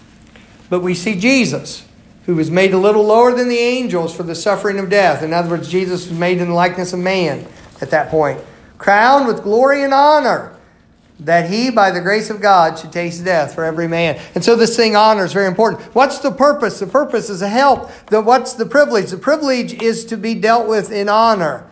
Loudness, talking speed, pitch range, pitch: -14 LUFS, 220 wpm, 180-235 Hz, 210 Hz